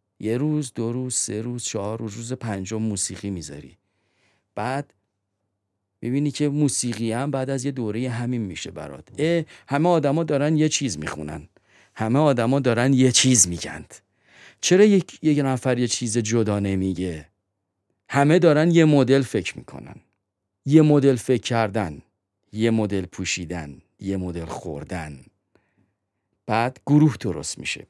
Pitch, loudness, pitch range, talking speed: 115 Hz, -22 LUFS, 95-135 Hz, 140 wpm